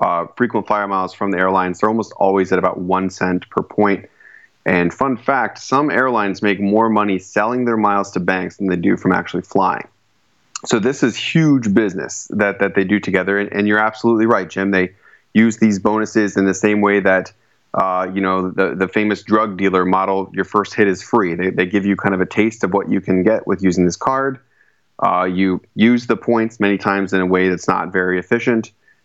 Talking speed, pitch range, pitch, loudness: 215 wpm, 95-110 Hz, 100 Hz, -17 LUFS